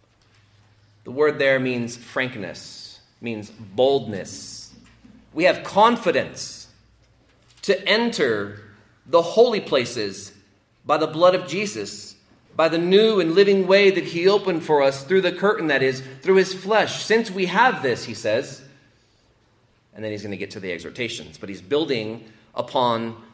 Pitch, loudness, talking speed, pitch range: 130 Hz, -21 LUFS, 150 wpm, 110-180 Hz